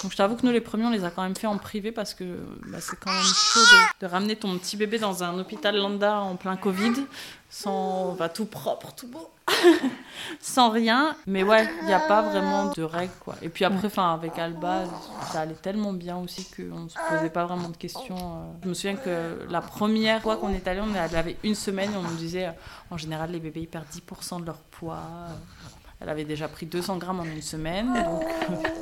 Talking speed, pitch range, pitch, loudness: 230 wpm, 170-210 Hz, 185 Hz, -25 LUFS